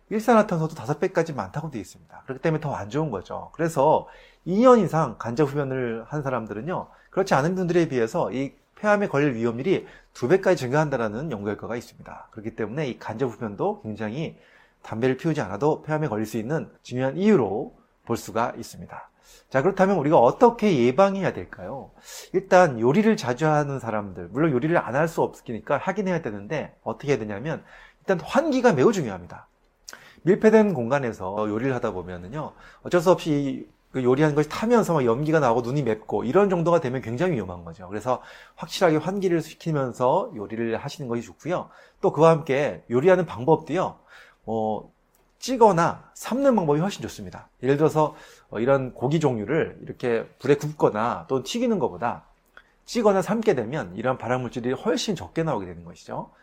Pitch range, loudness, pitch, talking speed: 120-180 Hz, -24 LUFS, 150 Hz, 385 characters per minute